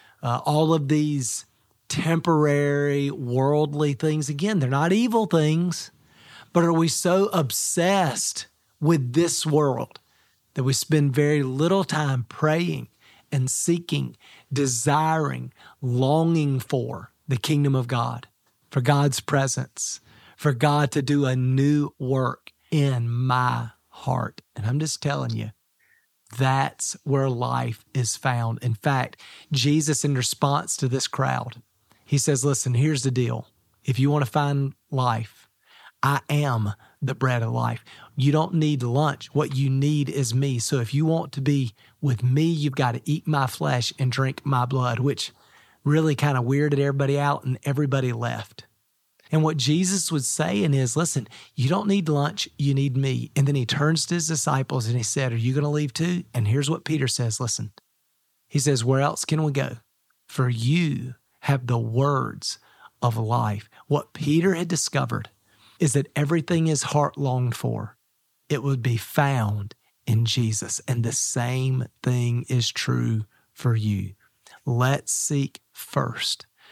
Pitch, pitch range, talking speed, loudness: 140 Hz, 125-150 Hz, 155 wpm, -24 LUFS